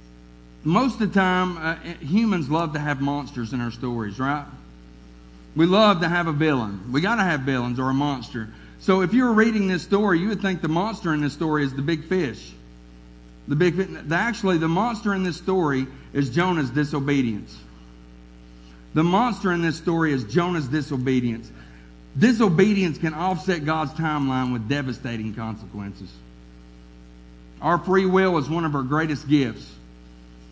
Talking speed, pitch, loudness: 165 wpm, 145 Hz, -23 LUFS